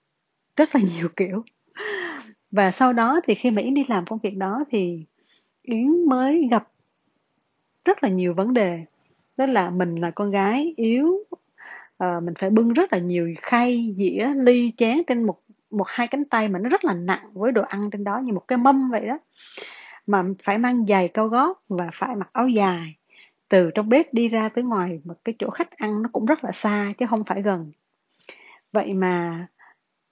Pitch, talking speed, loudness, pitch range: 220 Hz, 195 wpm, -22 LUFS, 190-255 Hz